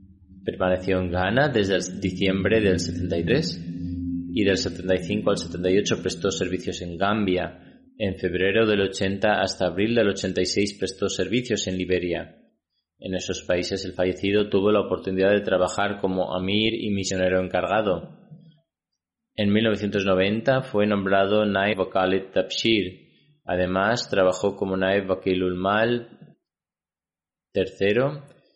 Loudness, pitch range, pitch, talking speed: -24 LUFS, 90-105 Hz, 95 Hz, 120 wpm